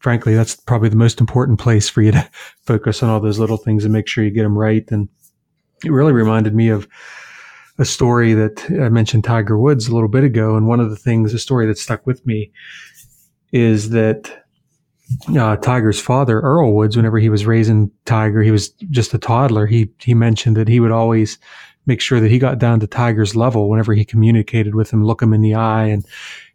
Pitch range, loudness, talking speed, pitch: 110-120 Hz, -15 LUFS, 215 wpm, 115 Hz